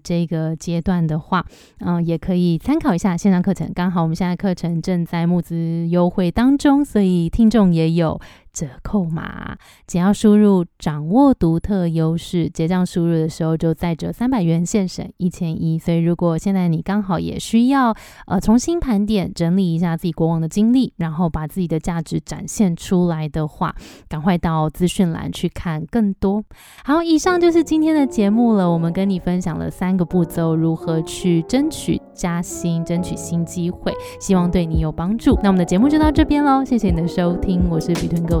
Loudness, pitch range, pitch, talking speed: -18 LUFS, 165-205 Hz, 180 Hz, 295 characters per minute